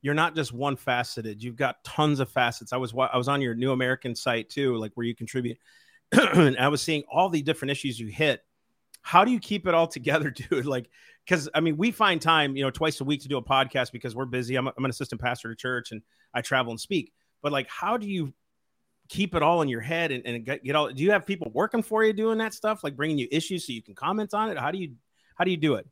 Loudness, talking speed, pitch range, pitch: -26 LUFS, 275 wpm, 125-165 Hz, 140 Hz